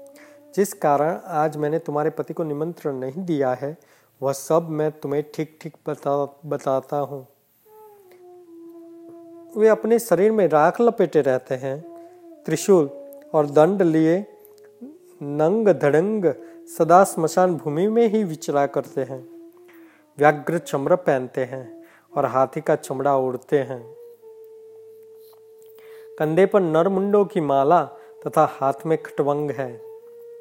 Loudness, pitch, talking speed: -21 LUFS, 170 Hz, 120 wpm